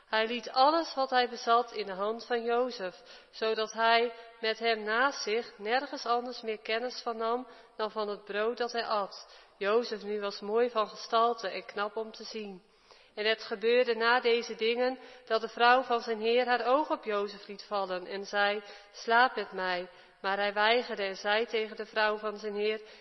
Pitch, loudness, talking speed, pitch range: 225 Hz, -30 LUFS, 195 wpm, 210-240 Hz